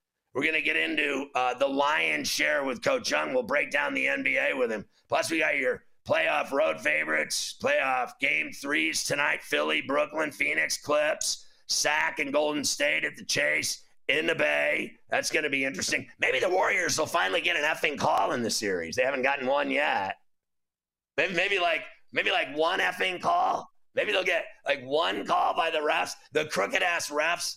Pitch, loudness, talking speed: 155 Hz, -26 LUFS, 185 wpm